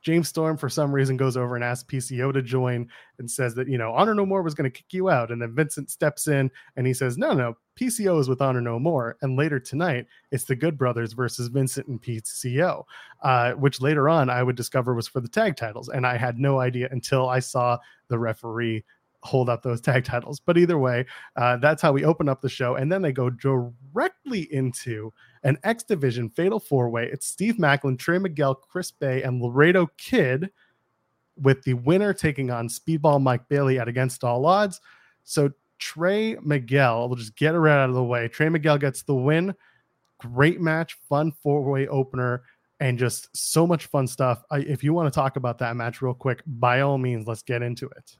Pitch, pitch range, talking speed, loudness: 135 Hz, 125-155 Hz, 215 wpm, -24 LUFS